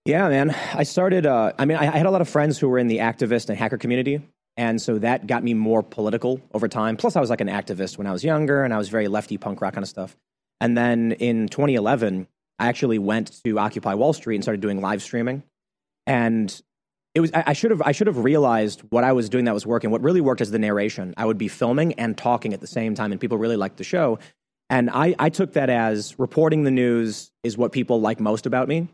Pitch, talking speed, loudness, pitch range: 120 Hz, 255 wpm, -22 LUFS, 110-140 Hz